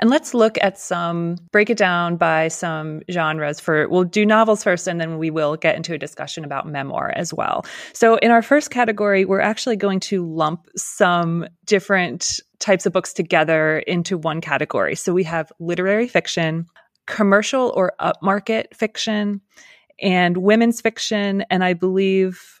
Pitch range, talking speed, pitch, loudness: 165-210 Hz, 165 wpm, 185 Hz, -19 LUFS